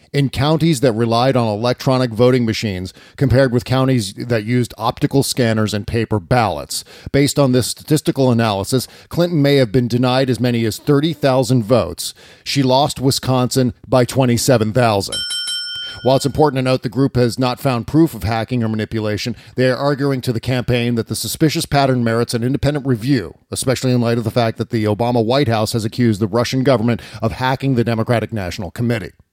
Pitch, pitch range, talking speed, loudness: 125 Hz, 115-135 Hz, 180 wpm, -17 LUFS